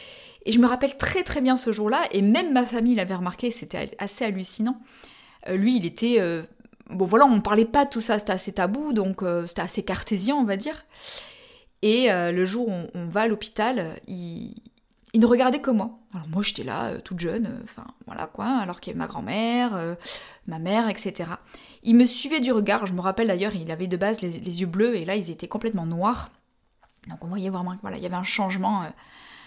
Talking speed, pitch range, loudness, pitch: 230 wpm, 190-240 Hz, -24 LUFS, 215 Hz